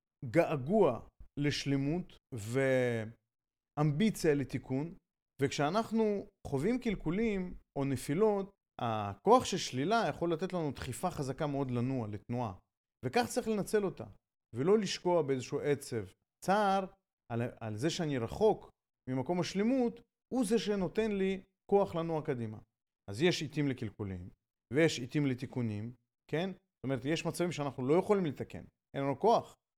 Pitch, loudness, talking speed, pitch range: 150 Hz, -34 LUFS, 125 wpm, 130-190 Hz